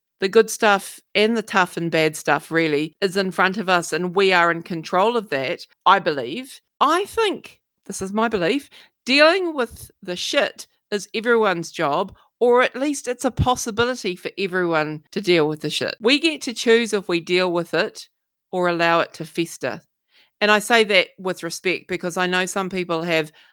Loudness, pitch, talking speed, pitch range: -20 LUFS, 190 Hz, 195 wpm, 170-235 Hz